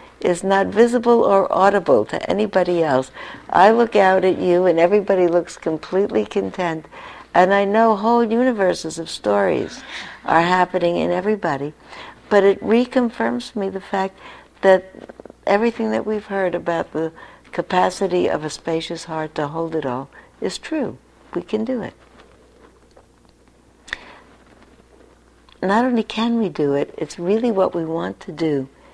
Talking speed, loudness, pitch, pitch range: 145 wpm, -19 LUFS, 185 Hz, 165-215 Hz